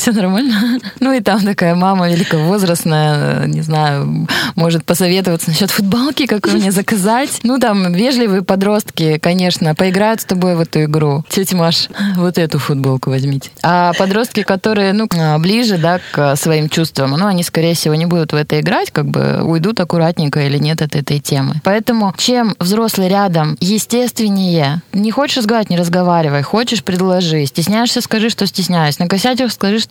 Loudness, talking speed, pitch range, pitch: -13 LUFS, 165 wpm, 160-210 Hz, 185 Hz